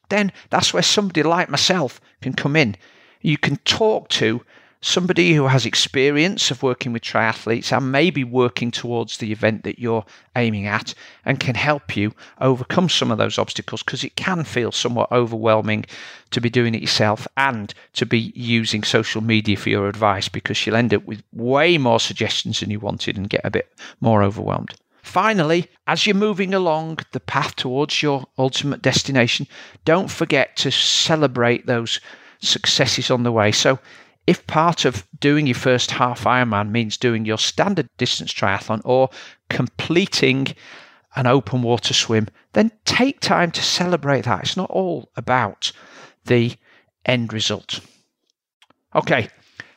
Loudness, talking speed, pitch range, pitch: -19 LUFS, 160 wpm, 110-145 Hz, 125 Hz